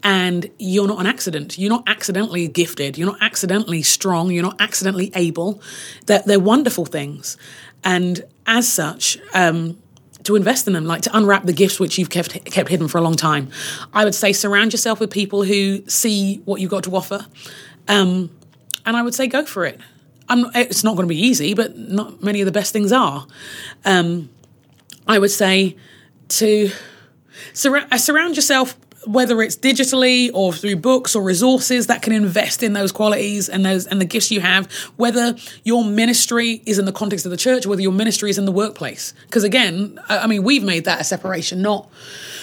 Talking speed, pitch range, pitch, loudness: 200 wpm, 185-225 Hz, 200 Hz, -17 LUFS